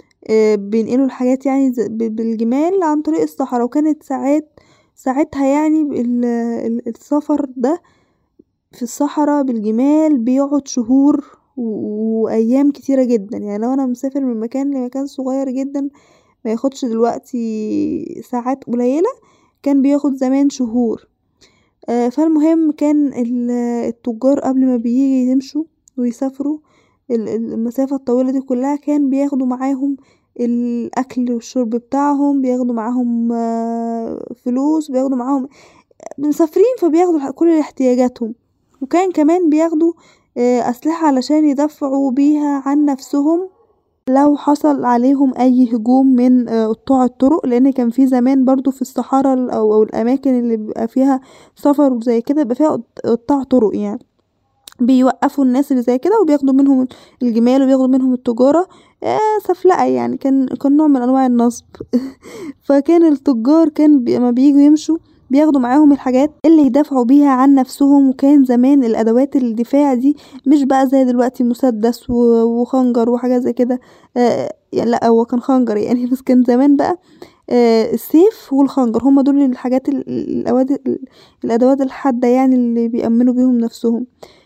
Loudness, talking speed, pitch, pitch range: -15 LUFS, 125 wpm, 265 Hz, 245-285 Hz